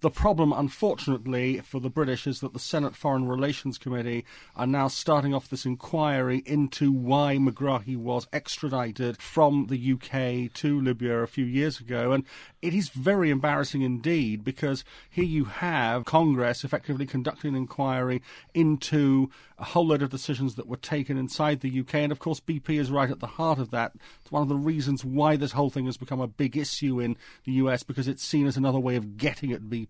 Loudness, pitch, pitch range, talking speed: -27 LUFS, 135 Hz, 130-150 Hz, 195 wpm